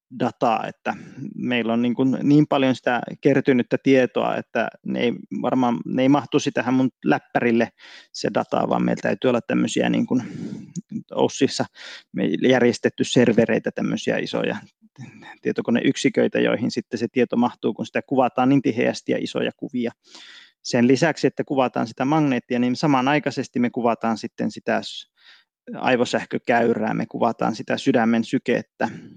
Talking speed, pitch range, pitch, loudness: 140 wpm, 120-140 Hz, 130 Hz, -22 LUFS